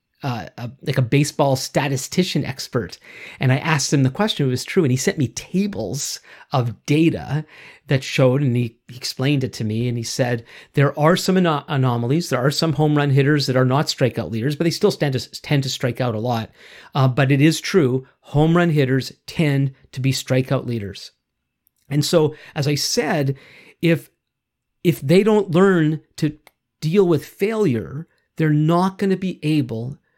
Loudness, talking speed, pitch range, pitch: -20 LUFS, 190 wpm, 130-160 Hz, 145 Hz